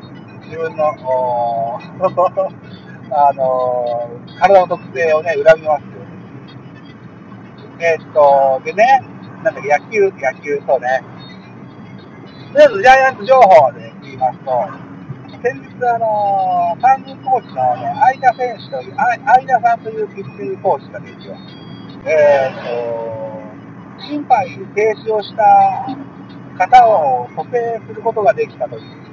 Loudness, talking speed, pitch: -14 LUFS, 245 characters per minute, 190 Hz